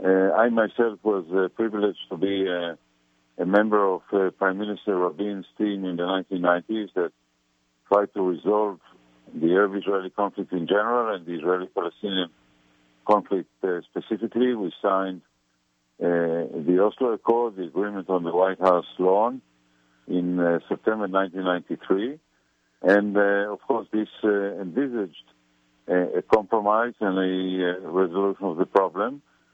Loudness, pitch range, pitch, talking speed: -24 LUFS, 85-105 Hz, 95 Hz, 140 wpm